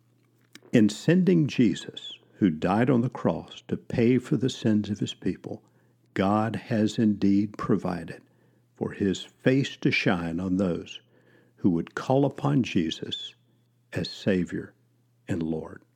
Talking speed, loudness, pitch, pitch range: 135 wpm, -26 LUFS, 115 Hz, 100-130 Hz